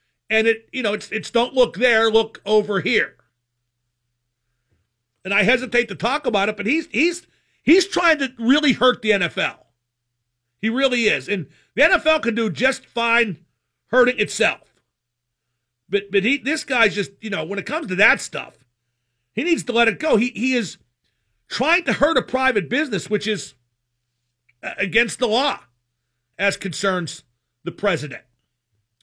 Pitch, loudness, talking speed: 205 Hz, -19 LUFS, 165 wpm